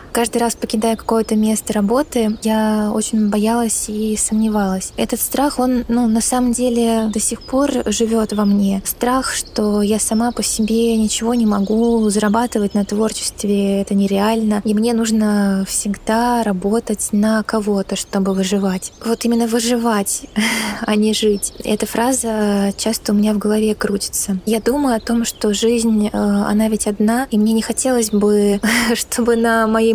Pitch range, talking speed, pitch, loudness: 210-235 Hz, 155 wpm, 220 Hz, -17 LUFS